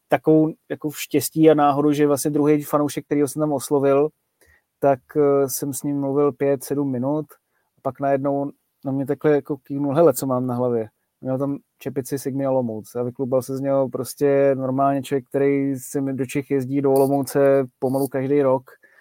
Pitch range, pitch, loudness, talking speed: 135-145 Hz, 140 Hz, -21 LUFS, 185 wpm